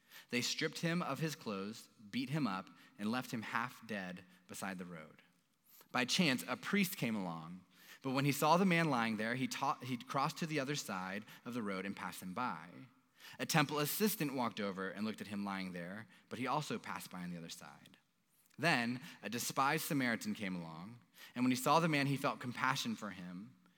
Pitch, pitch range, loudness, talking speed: 125 Hz, 100-150 Hz, -38 LUFS, 210 wpm